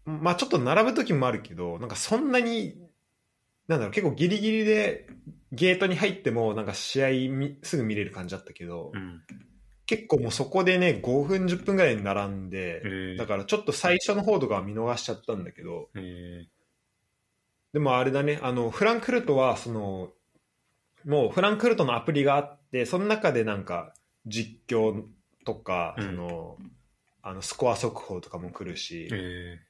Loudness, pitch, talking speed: -27 LUFS, 125 Hz, 320 characters per minute